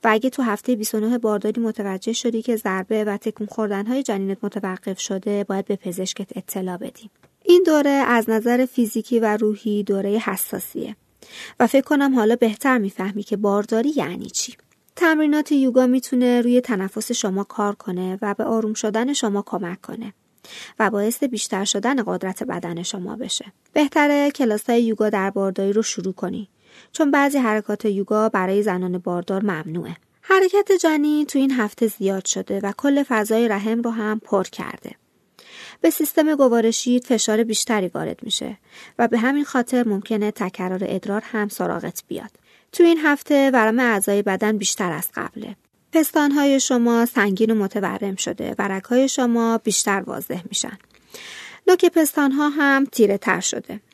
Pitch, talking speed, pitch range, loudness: 220 Hz, 155 wpm, 200-255 Hz, -20 LUFS